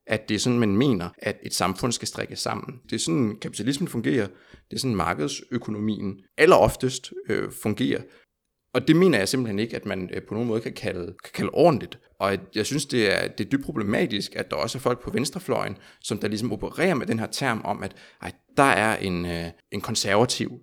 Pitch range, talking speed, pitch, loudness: 95-125 Hz, 220 wpm, 110 Hz, -25 LUFS